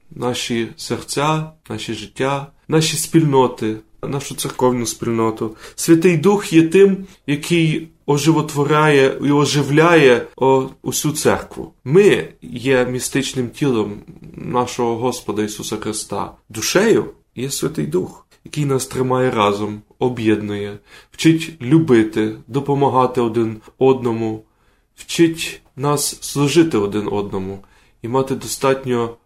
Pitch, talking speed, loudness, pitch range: 130 Hz, 100 wpm, -17 LUFS, 115-150 Hz